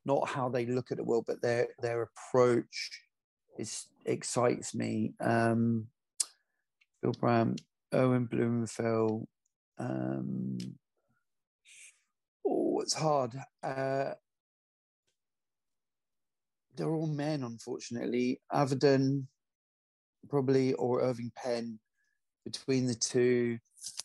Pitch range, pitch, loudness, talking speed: 115-135 Hz, 120 Hz, -32 LUFS, 85 wpm